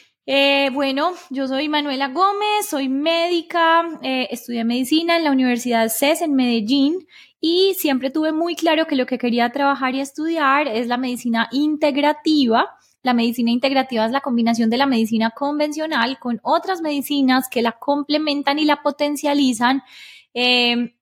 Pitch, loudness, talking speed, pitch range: 280 Hz, -19 LUFS, 150 wpm, 245-310 Hz